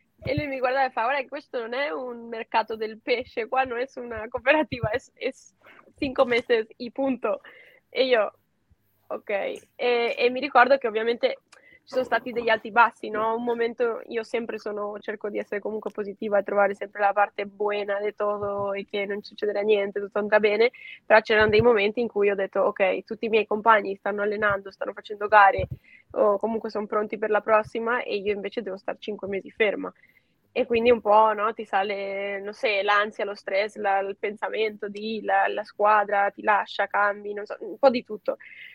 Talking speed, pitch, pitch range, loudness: 200 wpm, 215 Hz, 205-240 Hz, -25 LUFS